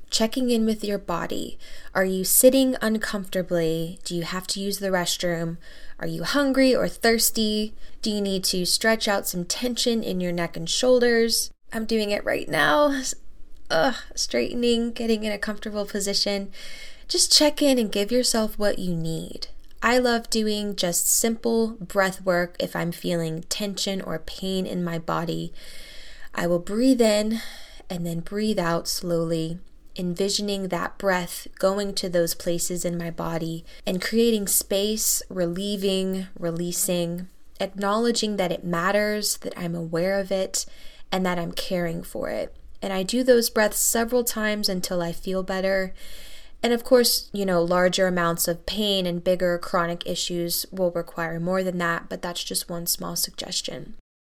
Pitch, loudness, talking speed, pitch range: 190 Hz, -24 LUFS, 160 wpm, 175-220 Hz